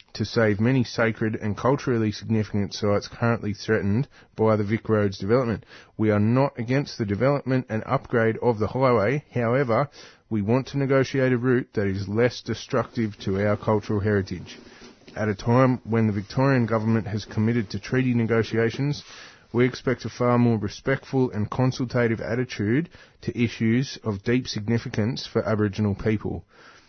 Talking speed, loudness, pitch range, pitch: 155 wpm, -24 LUFS, 105-125 Hz, 115 Hz